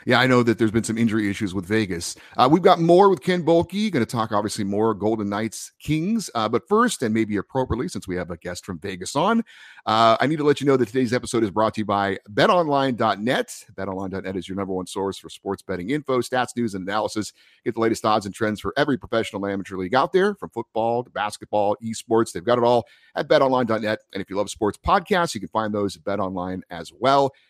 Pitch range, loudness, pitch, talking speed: 100-135 Hz, -22 LUFS, 110 Hz, 235 wpm